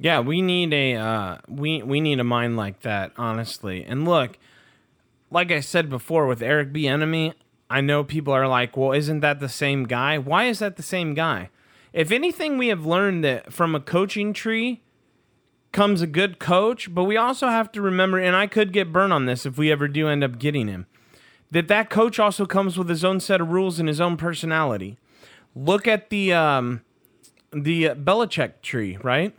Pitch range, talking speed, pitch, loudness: 135-190 Hz, 200 wpm, 160 Hz, -22 LUFS